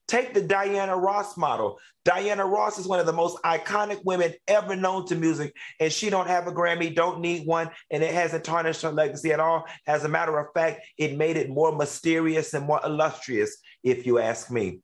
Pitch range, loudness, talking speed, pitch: 155-195 Hz, -25 LUFS, 210 wpm, 165 Hz